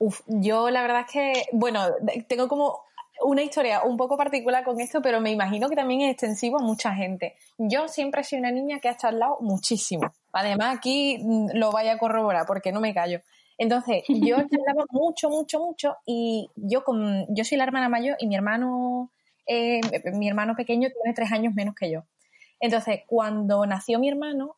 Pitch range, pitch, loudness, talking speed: 220-275 Hz, 240 Hz, -25 LUFS, 190 wpm